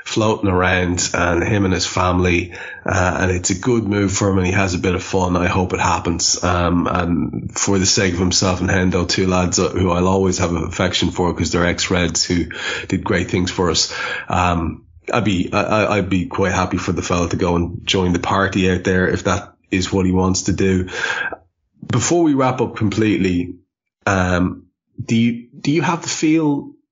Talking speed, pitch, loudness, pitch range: 205 wpm, 95 Hz, -18 LUFS, 90-100 Hz